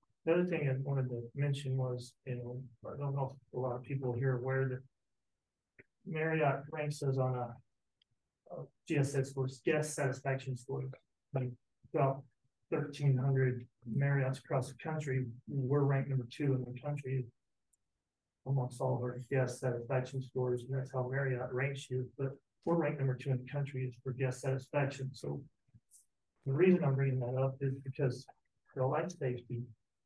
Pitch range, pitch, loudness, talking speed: 125-140 Hz, 130 Hz, -36 LUFS, 170 wpm